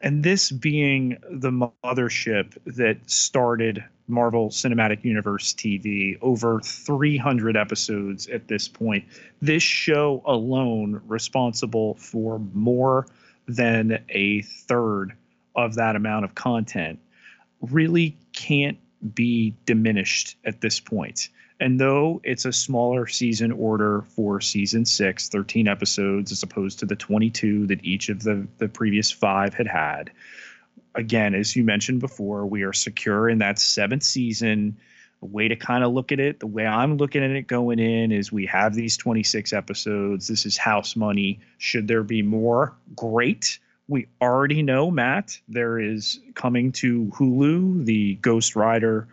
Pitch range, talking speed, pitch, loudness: 105-125 Hz, 145 wpm, 115 Hz, -23 LUFS